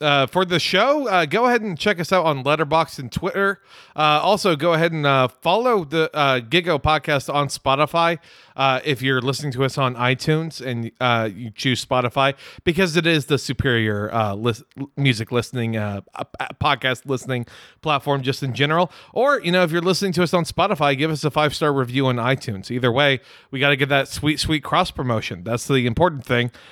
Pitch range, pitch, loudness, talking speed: 130-165 Hz, 140 Hz, -20 LUFS, 200 wpm